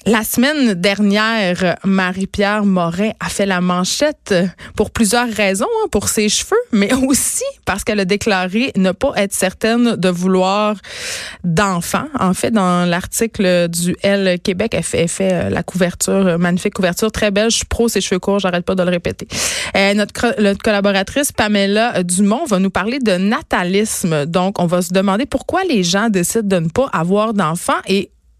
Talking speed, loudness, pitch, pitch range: 175 wpm, -16 LUFS, 200 Hz, 185-225 Hz